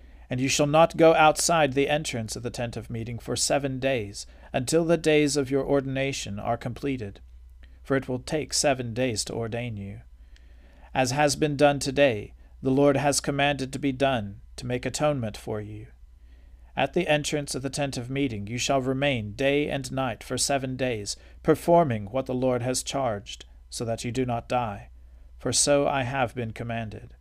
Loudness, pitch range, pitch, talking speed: -26 LUFS, 105-140 Hz, 130 Hz, 185 wpm